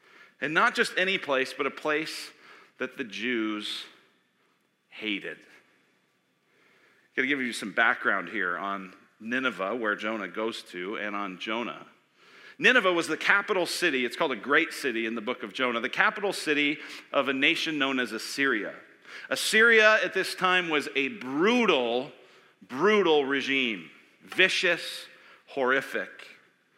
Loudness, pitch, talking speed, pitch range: -26 LUFS, 135 Hz, 145 wpm, 110-175 Hz